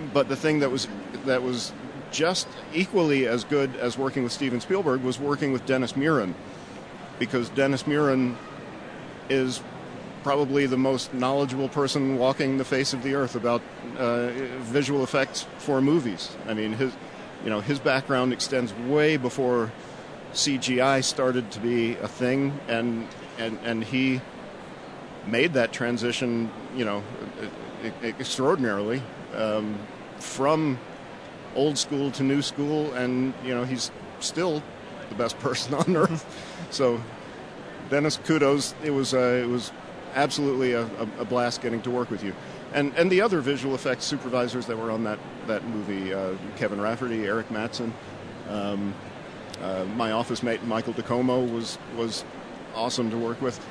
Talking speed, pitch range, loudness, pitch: 150 wpm, 115-140 Hz, -26 LUFS, 125 Hz